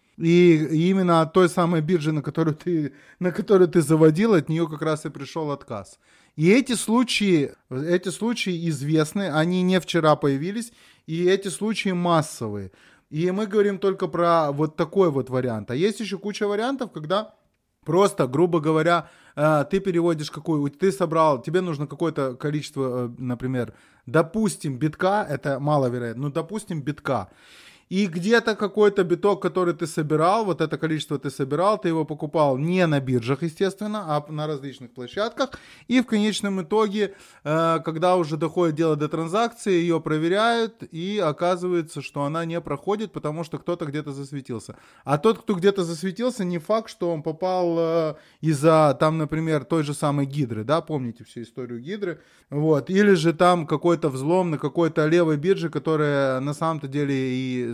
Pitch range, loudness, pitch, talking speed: 150-185 Hz, -23 LUFS, 165 Hz, 160 wpm